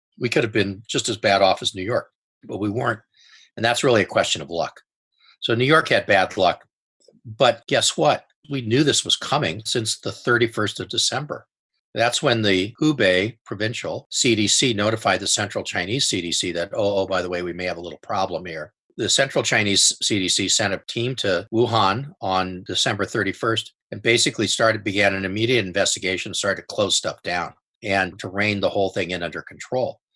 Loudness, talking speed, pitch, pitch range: -21 LUFS, 195 wpm, 110 Hz, 95-120 Hz